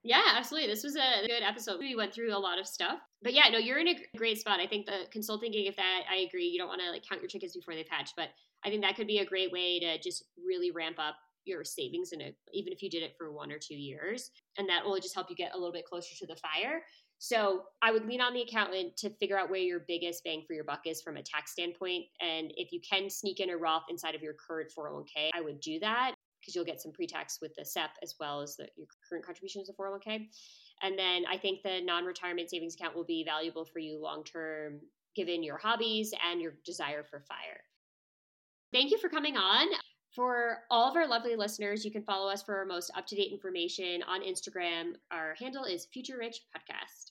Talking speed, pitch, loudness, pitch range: 250 wpm, 190 Hz, -34 LUFS, 170-225 Hz